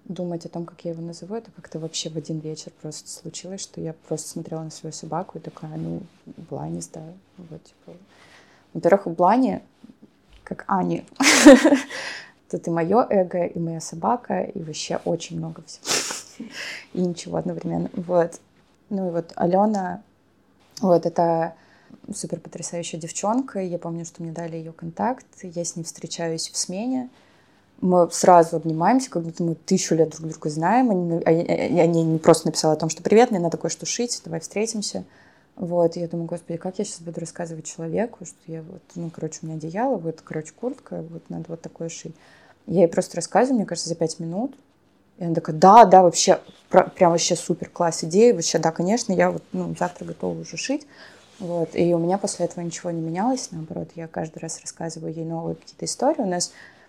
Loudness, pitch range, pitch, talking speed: -22 LUFS, 165-190 Hz, 170 Hz, 185 wpm